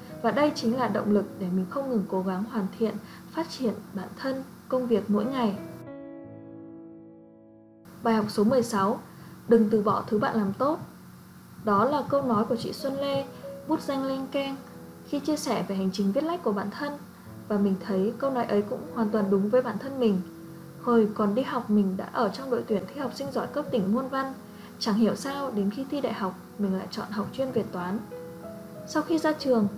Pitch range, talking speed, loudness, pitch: 195-265 Hz, 215 wpm, -28 LUFS, 220 Hz